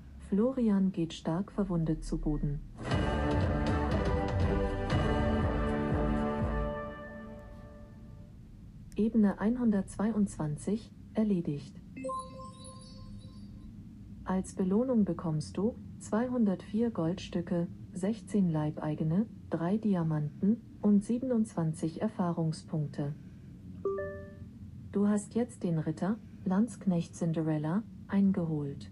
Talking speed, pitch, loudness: 60 wpm, 165 Hz, -32 LUFS